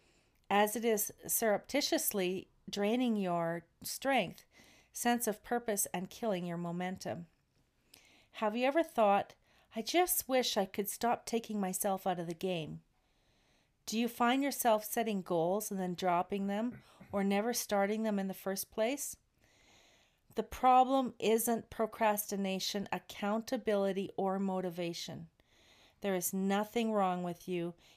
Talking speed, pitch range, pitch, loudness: 130 wpm, 185-230 Hz, 205 Hz, -34 LUFS